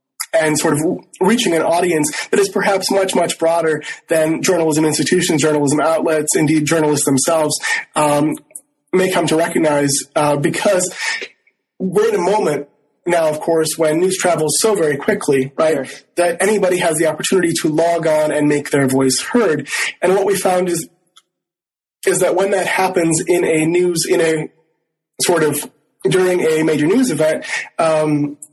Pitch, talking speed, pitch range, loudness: 165 Hz, 160 wpm, 155-185 Hz, -16 LUFS